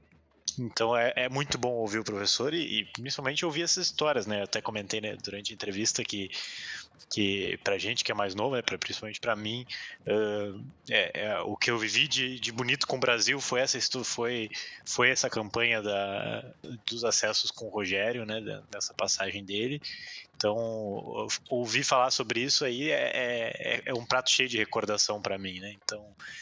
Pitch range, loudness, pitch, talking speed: 105-125 Hz, -29 LUFS, 110 Hz, 185 wpm